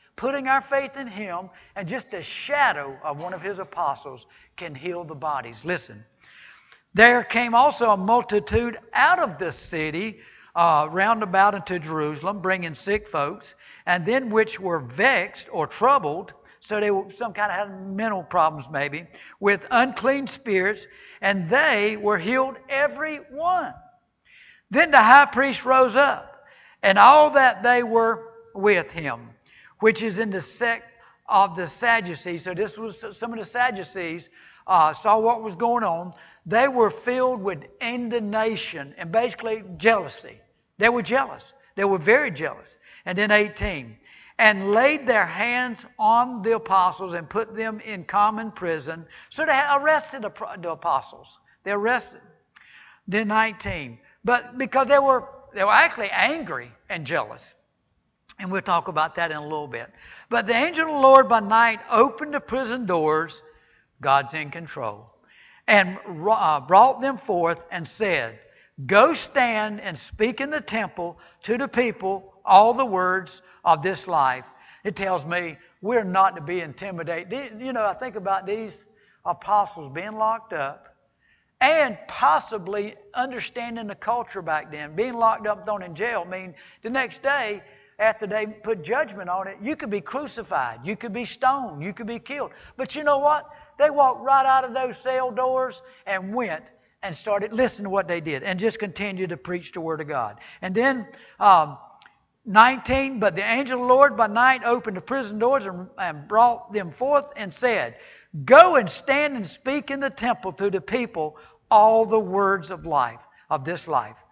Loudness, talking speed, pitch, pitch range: -22 LUFS, 165 wpm, 210 Hz, 180-245 Hz